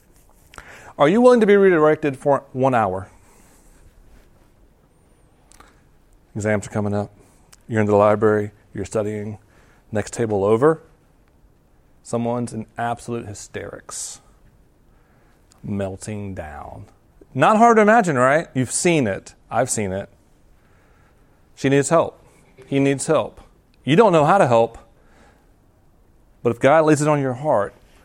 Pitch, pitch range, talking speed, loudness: 115 Hz, 105-140 Hz, 125 wpm, -19 LUFS